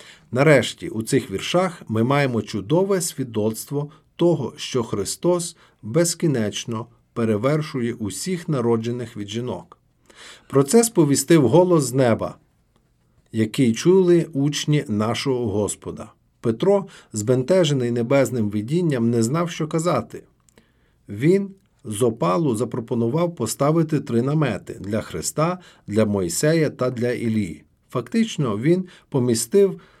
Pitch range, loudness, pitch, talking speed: 115-170 Hz, -21 LUFS, 135 Hz, 105 wpm